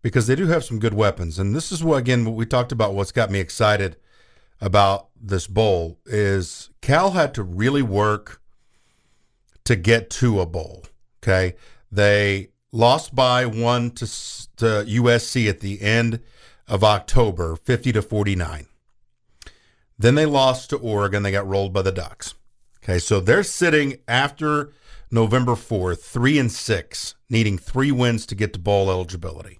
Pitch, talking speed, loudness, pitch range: 110 Hz, 160 wpm, -20 LUFS, 100-125 Hz